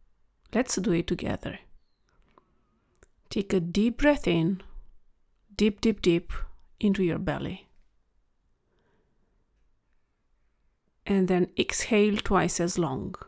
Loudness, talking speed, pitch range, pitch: -27 LUFS, 95 wpm, 170-210 Hz, 185 Hz